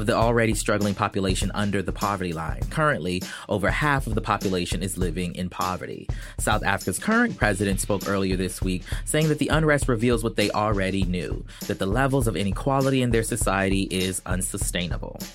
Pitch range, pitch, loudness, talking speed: 95-120 Hz, 105 Hz, -24 LUFS, 180 wpm